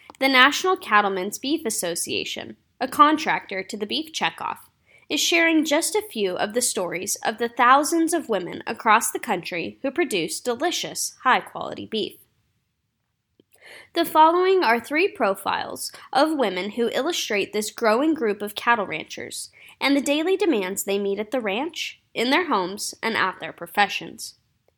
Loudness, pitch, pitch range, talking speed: -22 LUFS, 255 Hz, 210-320 Hz, 155 wpm